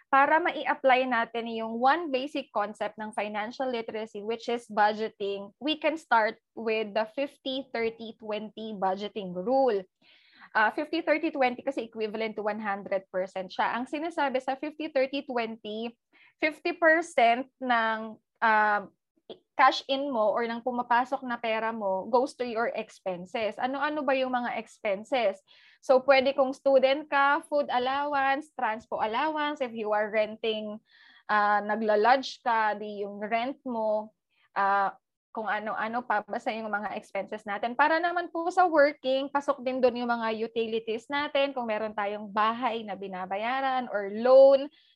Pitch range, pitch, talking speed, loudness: 215-275 Hz, 235 Hz, 135 wpm, -28 LUFS